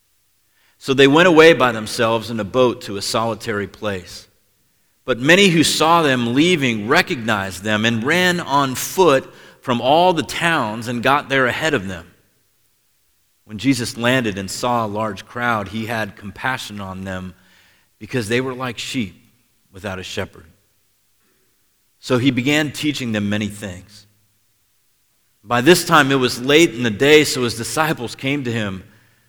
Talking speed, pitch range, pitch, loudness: 160 wpm, 105-130 Hz, 115 Hz, -17 LUFS